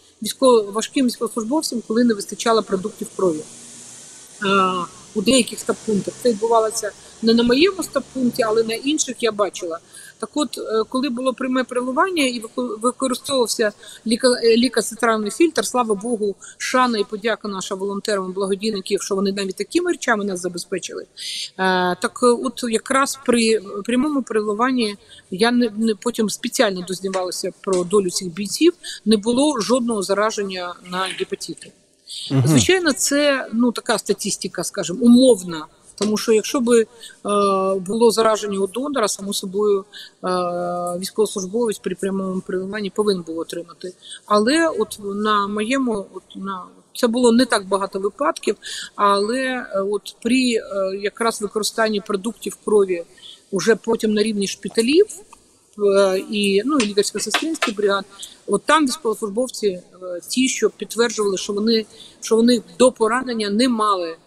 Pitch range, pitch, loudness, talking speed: 195-245 Hz, 215 Hz, -20 LUFS, 135 wpm